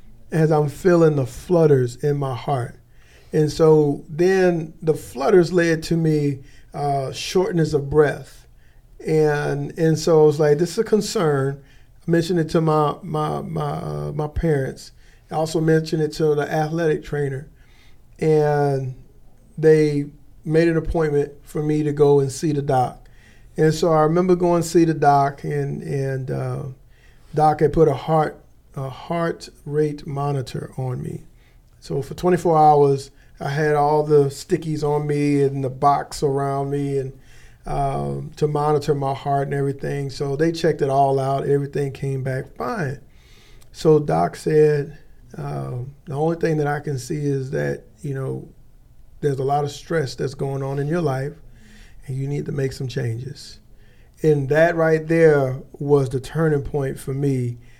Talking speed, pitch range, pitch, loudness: 165 wpm, 135-155 Hz, 145 Hz, -20 LUFS